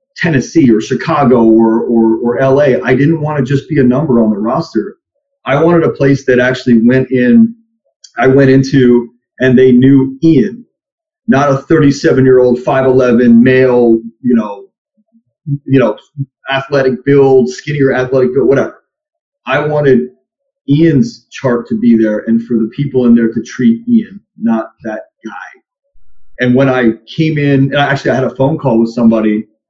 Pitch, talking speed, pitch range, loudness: 130 Hz, 165 wpm, 120-160 Hz, -10 LUFS